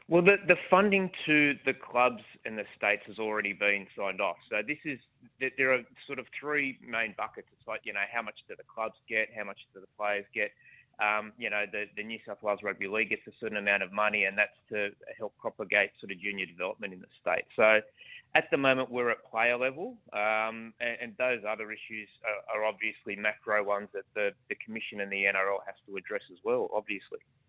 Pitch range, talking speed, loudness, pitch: 105-135 Hz, 220 wpm, -30 LUFS, 110 Hz